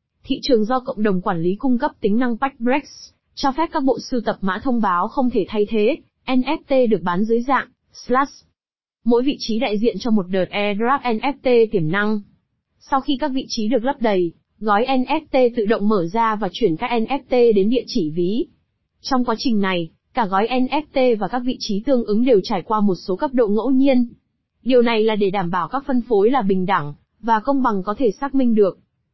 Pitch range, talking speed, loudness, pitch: 205-265 Hz, 220 wpm, -20 LUFS, 235 Hz